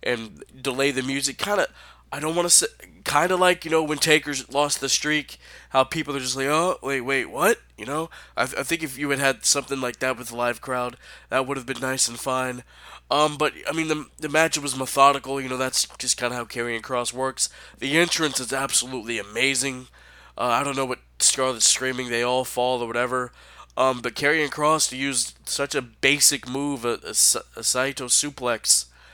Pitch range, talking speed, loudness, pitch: 125-145 Hz, 210 wpm, -22 LUFS, 135 Hz